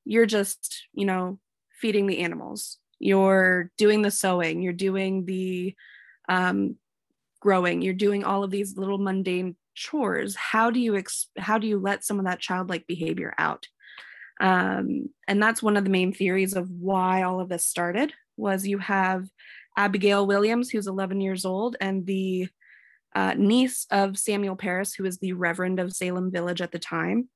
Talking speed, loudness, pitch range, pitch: 170 wpm, -25 LUFS, 185-205 Hz, 190 Hz